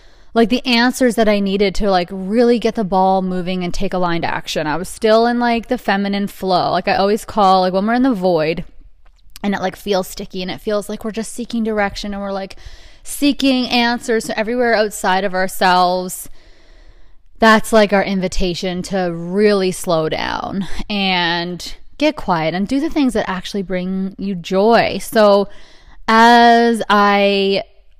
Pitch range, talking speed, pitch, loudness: 185-225 Hz, 175 wpm, 200 Hz, -16 LUFS